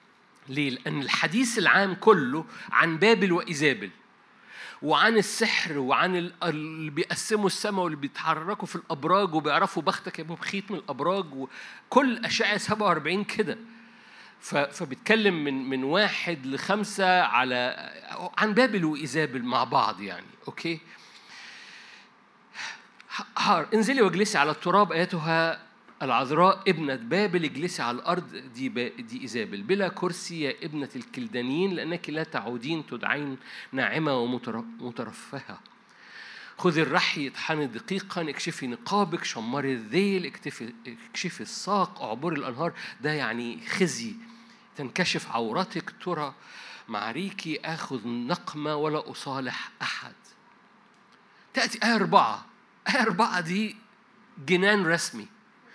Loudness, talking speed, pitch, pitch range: -27 LUFS, 105 wpm, 180 Hz, 150-205 Hz